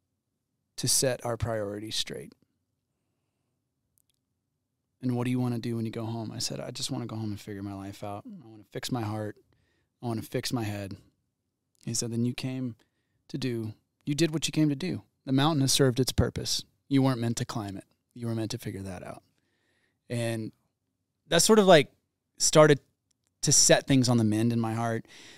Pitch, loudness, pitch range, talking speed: 120 Hz, -27 LUFS, 110-130 Hz, 200 wpm